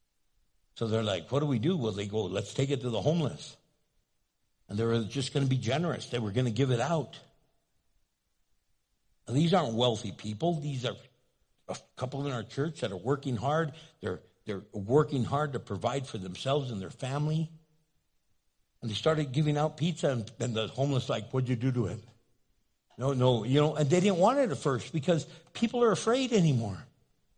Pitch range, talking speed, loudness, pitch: 115-155 Hz, 195 wpm, -30 LUFS, 135 Hz